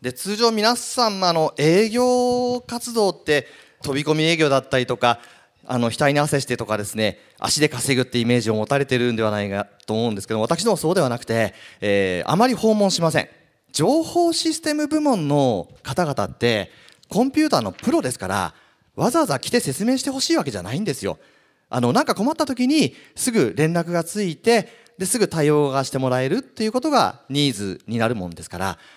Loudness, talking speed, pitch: -21 LUFS, 390 characters per minute, 155 Hz